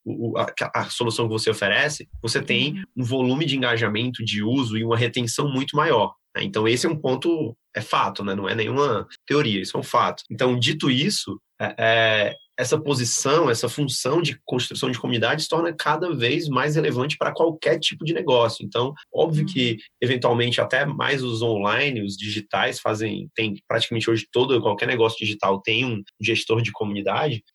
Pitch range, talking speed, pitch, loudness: 110-145 Hz, 180 wpm, 120 Hz, -22 LUFS